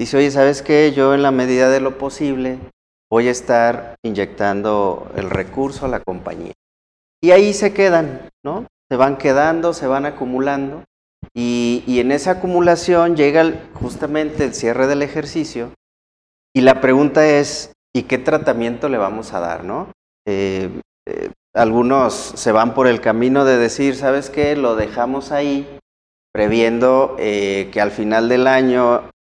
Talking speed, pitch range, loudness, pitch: 155 wpm, 115-145 Hz, -16 LUFS, 130 Hz